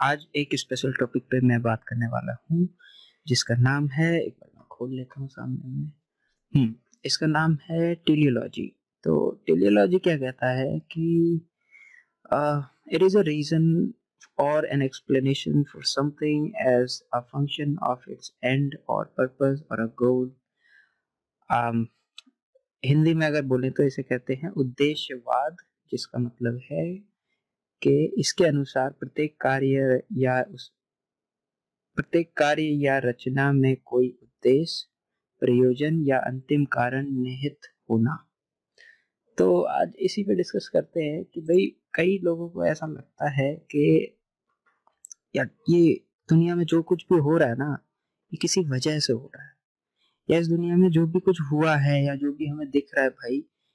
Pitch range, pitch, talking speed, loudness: 130-165 Hz, 145 Hz, 145 wpm, -25 LUFS